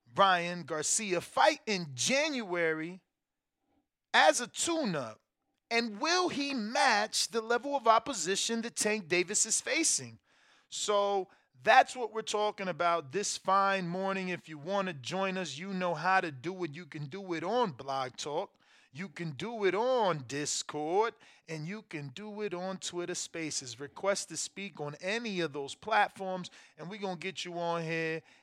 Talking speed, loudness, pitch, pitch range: 165 wpm, -31 LUFS, 190 Hz, 165-215 Hz